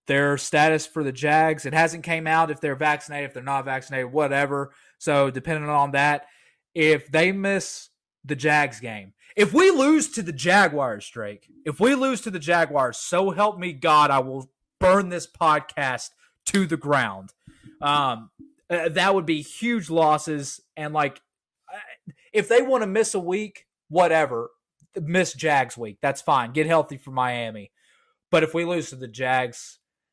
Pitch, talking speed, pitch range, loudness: 155 Hz, 170 wpm, 140-180 Hz, -22 LUFS